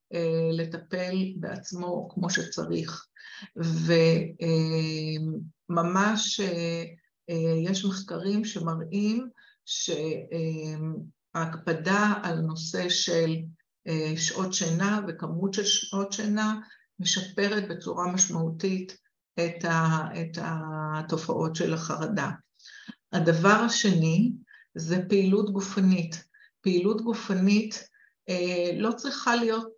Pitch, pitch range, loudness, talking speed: 180 Hz, 165-200 Hz, -27 LUFS, 85 wpm